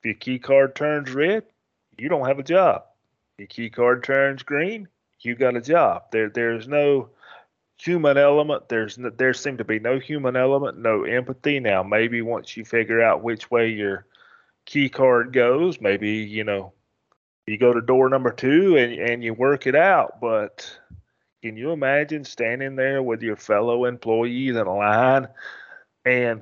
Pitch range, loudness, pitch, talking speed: 115-135 Hz, -21 LUFS, 125 Hz, 175 wpm